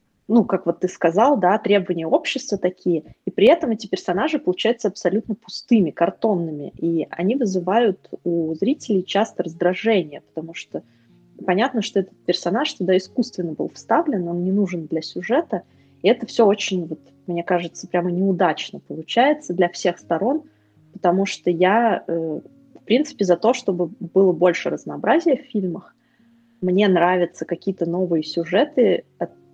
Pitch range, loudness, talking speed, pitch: 170-215 Hz, -21 LUFS, 145 wpm, 185 Hz